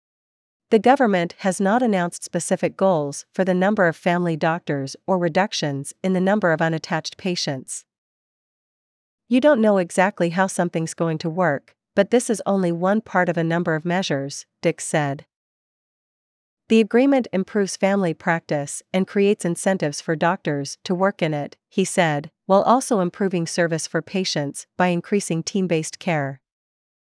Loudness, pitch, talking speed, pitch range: -21 LUFS, 180 Hz, 155 wpm, 165-195 Hz